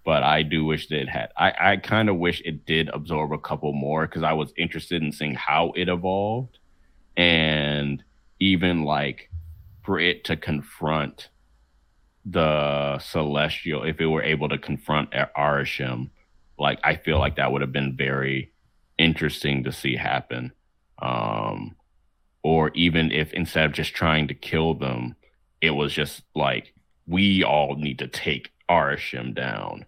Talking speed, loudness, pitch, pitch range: 160 wpm, -24 LUFS, 75 Hz, 70-80 Hz